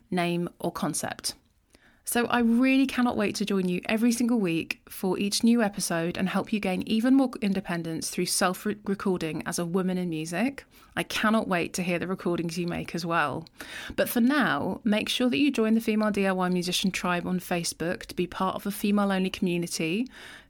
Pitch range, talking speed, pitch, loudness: 175-220 Hz, 200 wpm, 190 Hz, -27 LUFS